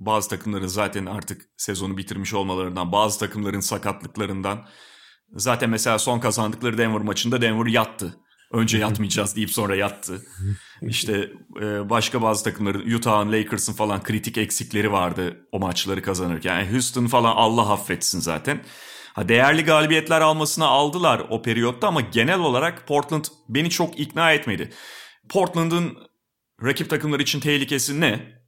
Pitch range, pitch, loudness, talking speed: 100-130 Hz, 110 Hz, -22 LUFS, 135 wpm